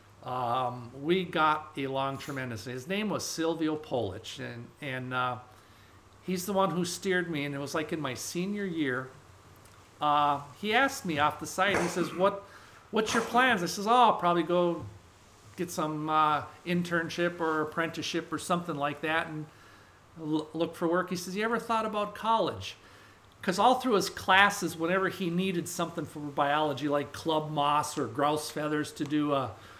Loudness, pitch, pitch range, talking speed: -30 LUFS, 155 Hz, 130-175 Hz, 175 wpm